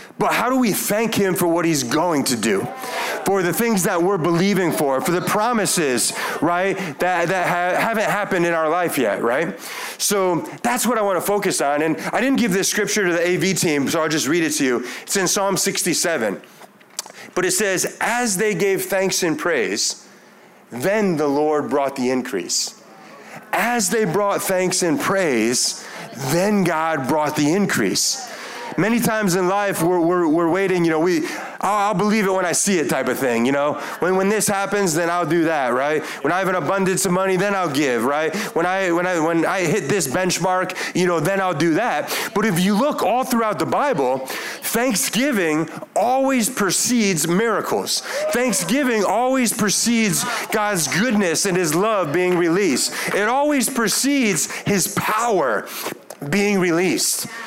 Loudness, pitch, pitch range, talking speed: -19 LUFS, 190 Hz, 170-215 Hz, 185 wpm